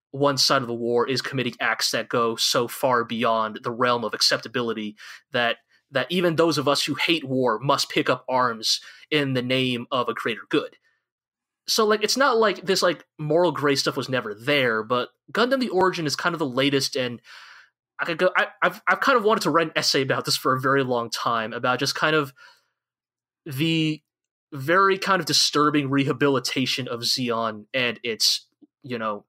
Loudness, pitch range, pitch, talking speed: -22 LUFS, 125-170 Hz, 140 Hz, 195 wpm